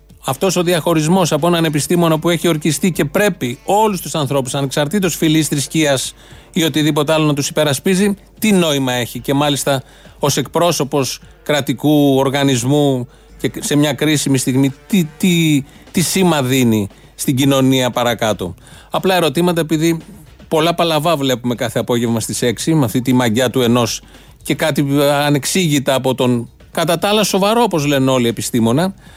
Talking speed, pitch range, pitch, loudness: 155 wpm, 130-170 Hz, 145 Hz, -15 LUFS